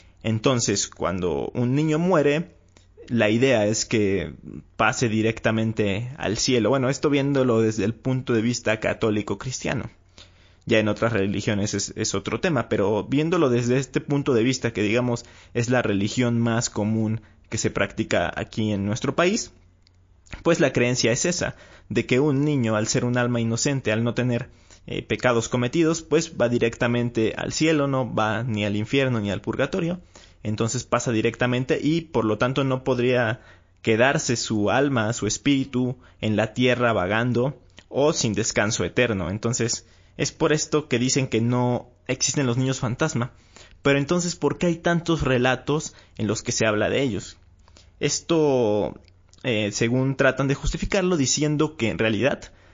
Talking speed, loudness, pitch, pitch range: 160 wpm, -23 LUFS, 120 Hz, 105-135 Hz